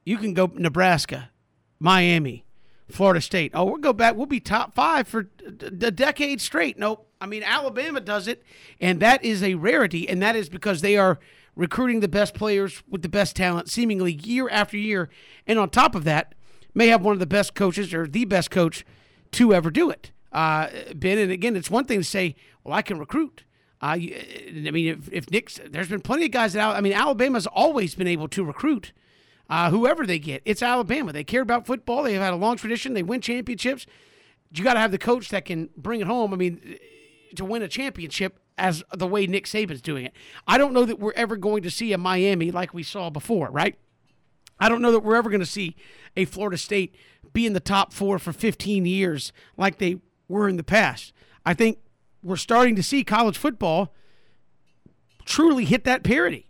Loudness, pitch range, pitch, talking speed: -23 LUFS, 180-230 Hz, 205 Hz, 210 wpm